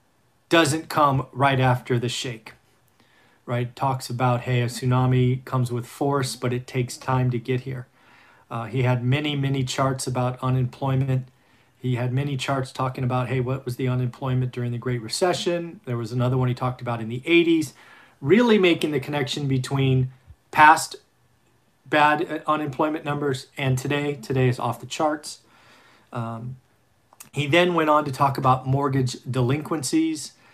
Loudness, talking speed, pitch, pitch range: -23 LUFS, 160 wpm, 130 Hz, 125-145 Hz